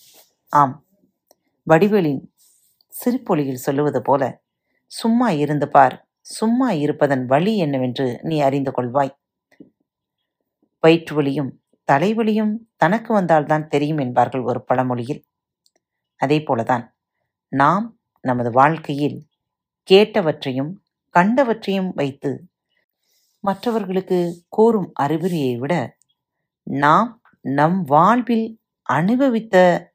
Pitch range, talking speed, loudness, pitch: 140-200 Hz, 80 wpm, -19 LUFS, 155 Hz